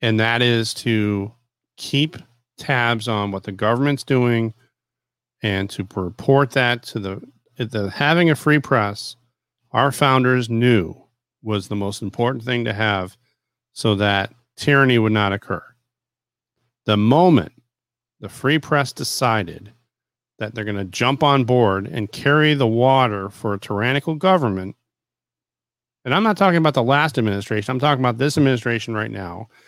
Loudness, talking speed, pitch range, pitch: -19 LUFS, 150 wpm, 105-130 Hz, 120 Hz